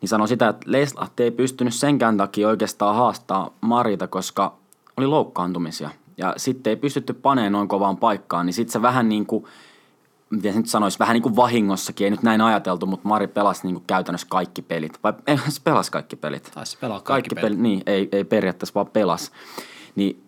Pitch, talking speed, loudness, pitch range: 110 Hz, 190 wpm, -22 LUFS, 95-120 Hz